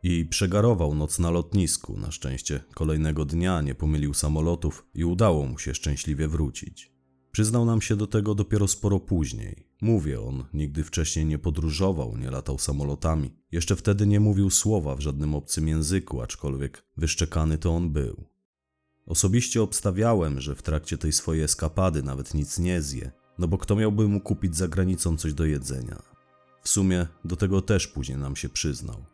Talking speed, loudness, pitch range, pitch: 165 wpm, -26 LUFS, 75-95 Hz, 80 Hz